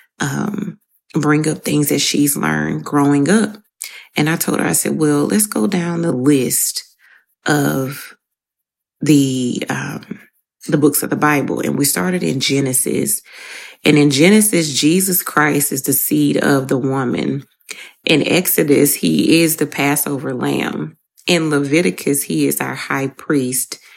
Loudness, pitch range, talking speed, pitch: -16 LUFS, 135-170 Hz, 150 wpm, 145 Hz